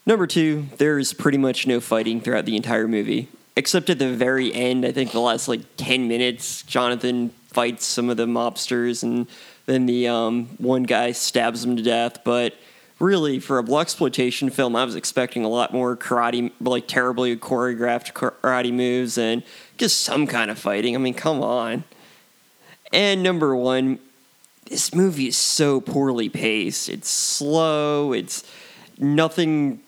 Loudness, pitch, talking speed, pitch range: -21 LUFS, 125 Hz, 165 wpm, 120-135 Hz